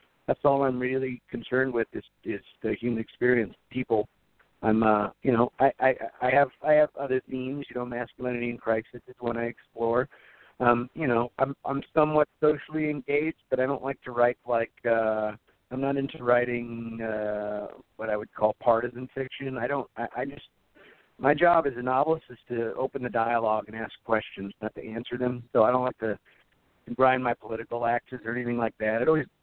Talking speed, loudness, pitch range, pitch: 200 wpm, -28 LUFS, 115-135 Hz, 120 Hz